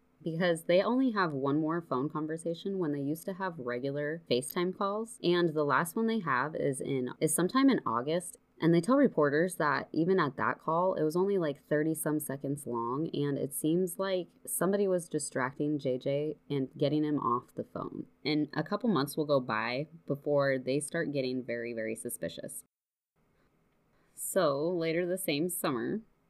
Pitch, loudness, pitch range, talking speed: 155 Hz, -31 LUFS, 140-180 Hz, 180 wpm